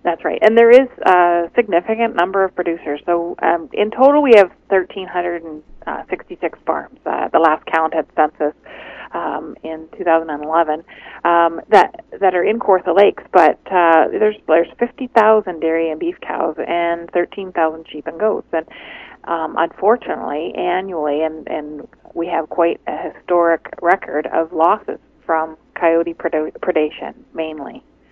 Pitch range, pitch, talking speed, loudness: 160-190 Hz, 170 Hz, 160 wpm, -17 LUFS